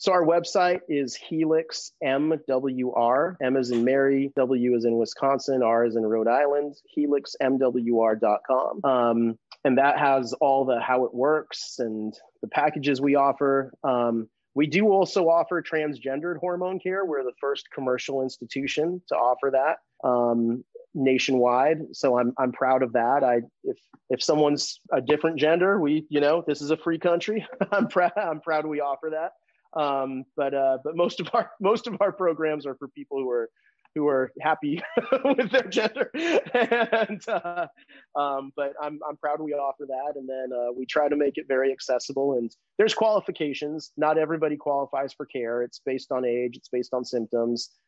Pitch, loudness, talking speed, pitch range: 145 Hz, -25 LUFS, 175 wpm, 130-170 Hz